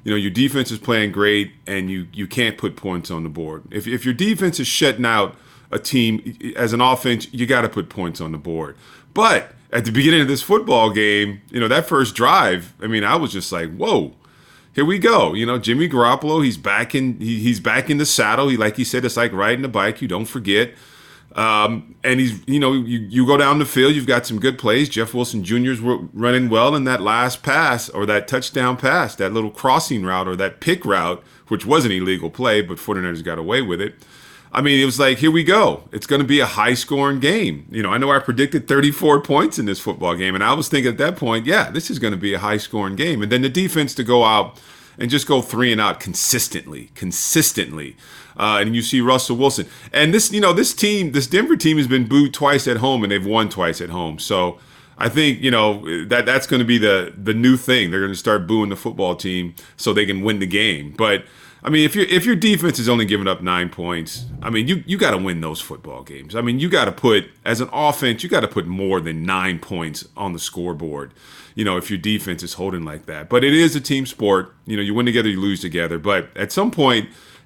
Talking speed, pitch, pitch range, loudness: 245 wpm, 120 Hz, 100-135 Hz, -18 LUFS